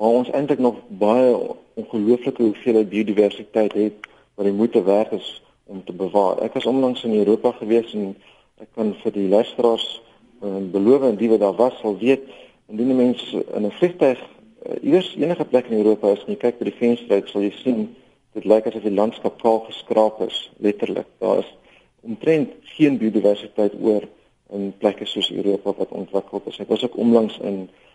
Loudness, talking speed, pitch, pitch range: -20 LUFS, 180 wpm, 110 Hz, 105-120 Hz